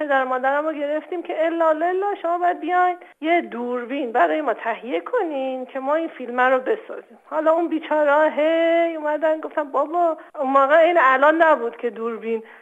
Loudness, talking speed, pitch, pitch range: -20 LUFS, 170 wpm, 310 Hz, 265-335 Hz